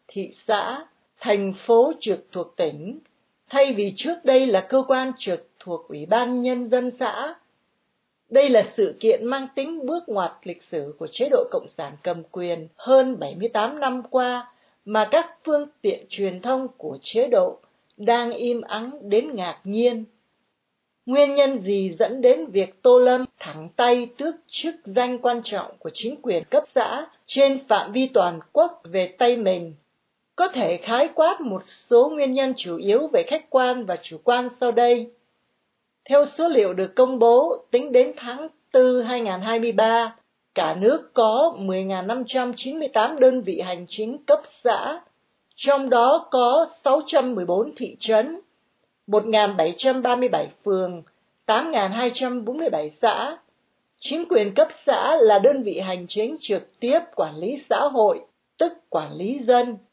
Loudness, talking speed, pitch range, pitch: -22 LUFS, 155 wpm, 210-285 Hz, 245 Hz